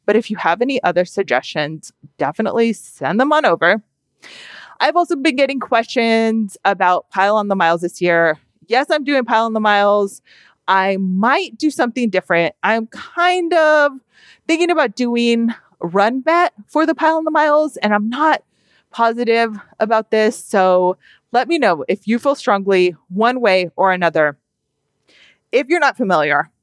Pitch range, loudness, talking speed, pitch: 190-275 Hz, -16 LUFS, 160 wpm, 225 Hz